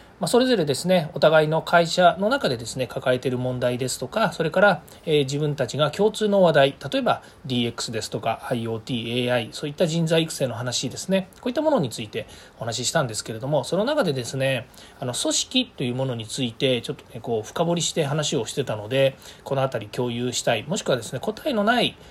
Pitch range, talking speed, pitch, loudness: 125-170 Hz, 430 characters per minute, 140 Hz, -23 LUFS